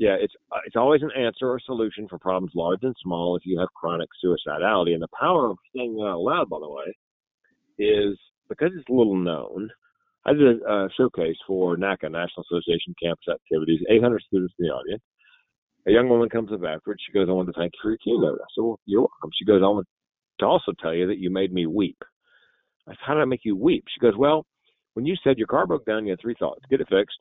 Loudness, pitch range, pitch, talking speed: -24 LUFS, 90-120 Hz, 105 Hz, 245 wpm